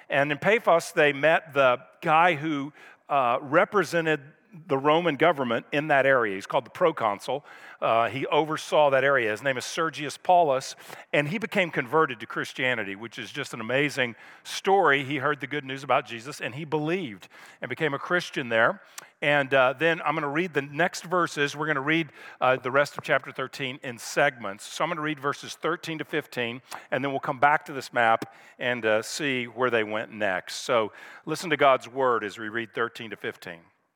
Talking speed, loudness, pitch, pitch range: 200 wpm, -25 LUFS, 145 Hz, 130-160 Hz